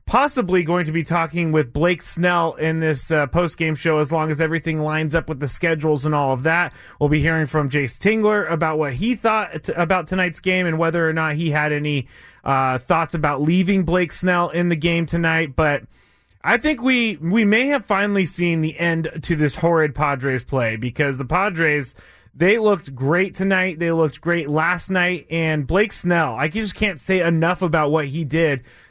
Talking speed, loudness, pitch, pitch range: 205 wpm, -19 LUFS, 165 Hz, 155-180 Hz